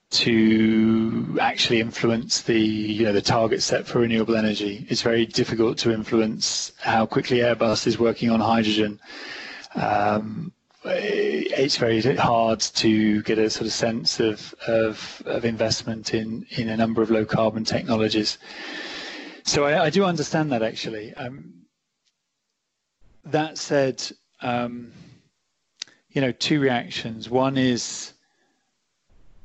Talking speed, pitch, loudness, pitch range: 130 wpm, 115 Hz, -22 LUFS, 110-130 Hz